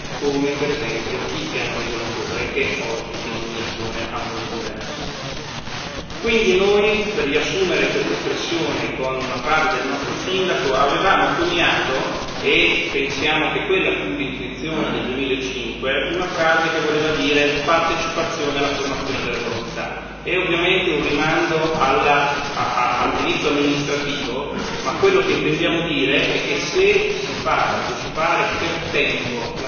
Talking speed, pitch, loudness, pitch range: 125 wpm, 145 Hz, -19 LUFS, 125-165 Hz